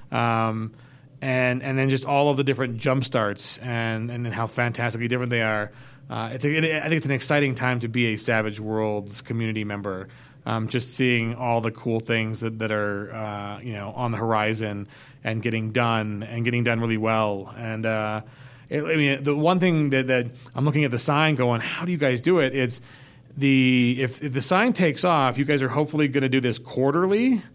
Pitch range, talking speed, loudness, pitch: 115-140 Hz, 215 wpm, -24 LUFS, 125 Hz